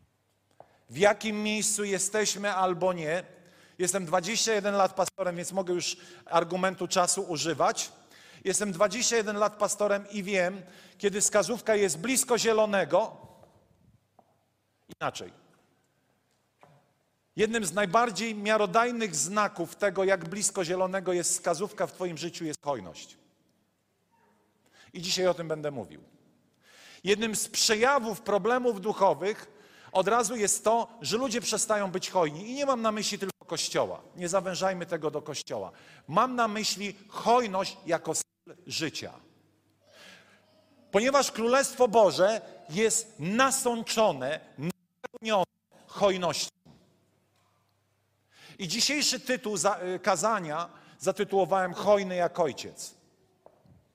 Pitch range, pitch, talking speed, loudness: 180-220 Hz, 195 Hz, 110 wpm, -28 LUFS